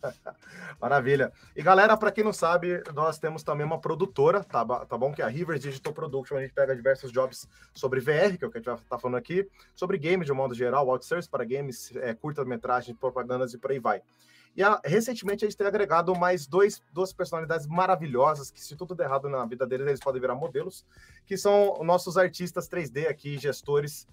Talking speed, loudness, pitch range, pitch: 210 wpm, -27 LUFS, 135-185 Hz, 155 Hz